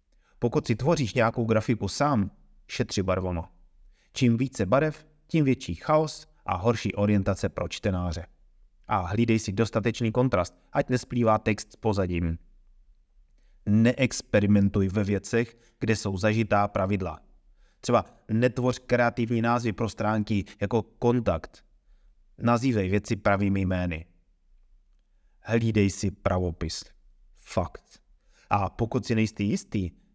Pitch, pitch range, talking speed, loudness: 105 Hz, 95-120 Hz, 115 wpm, -27 LUFS